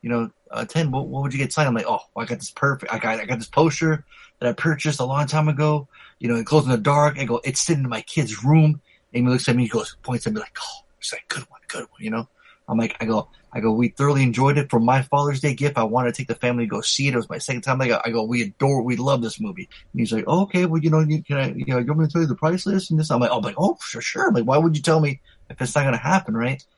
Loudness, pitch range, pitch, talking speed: -22 LUFS, 120-155 Hz, 135 Hz, 340 wpm